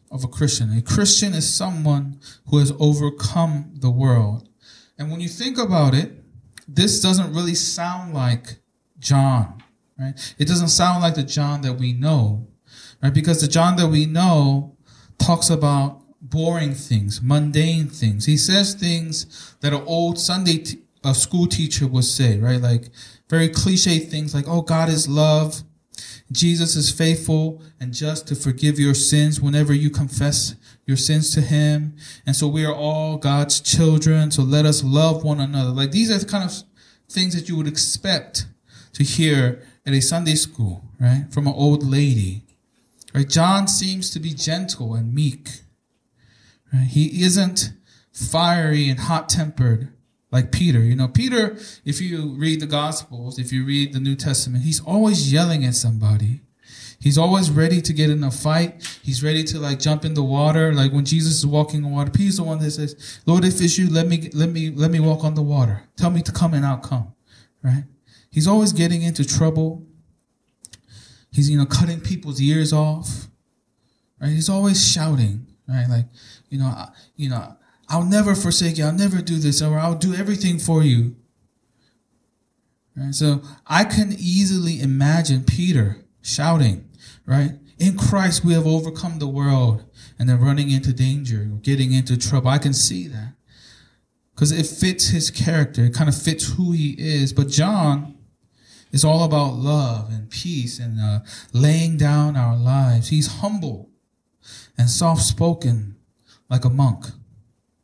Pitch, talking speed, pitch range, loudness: 145 Hz, 170 wpm, 125-160 Hz, -19 LUFS